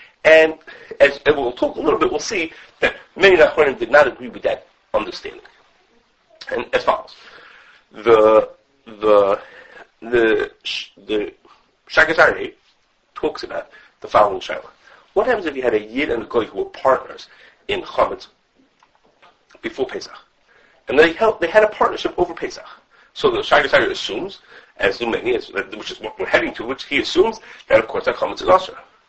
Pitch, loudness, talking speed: 370 Hz, -18 LUFS, 165 wpm